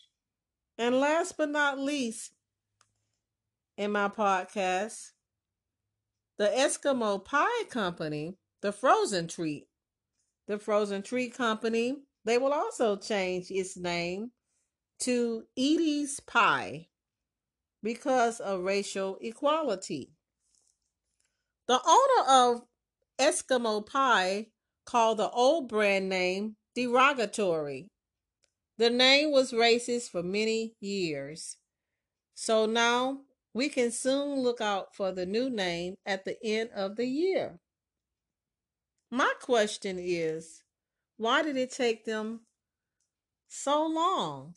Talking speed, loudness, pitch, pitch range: 105 wpm, -29 LUFS, 225 Hz, 190-260 Hz